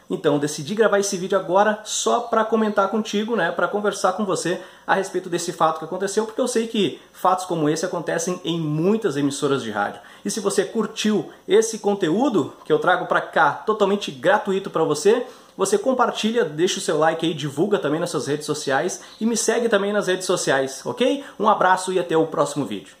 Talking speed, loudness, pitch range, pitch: 205 wpm, -21 LUFS, 165-215 Hz, 190 Hz